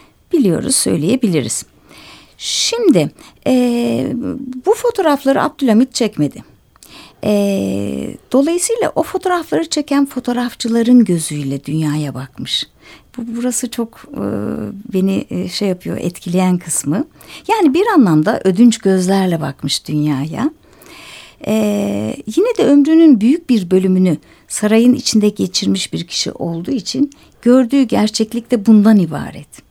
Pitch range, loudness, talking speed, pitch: 180-270 Hz, -15 LUFS, 105 wpm, 230 Hz